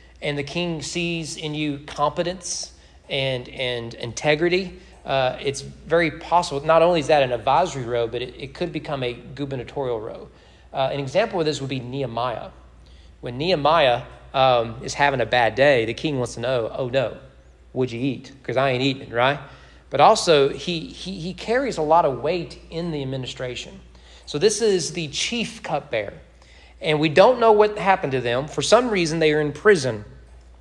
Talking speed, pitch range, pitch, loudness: 185 wpm, 125-165 Hz, 140 Hz, -22 LUFS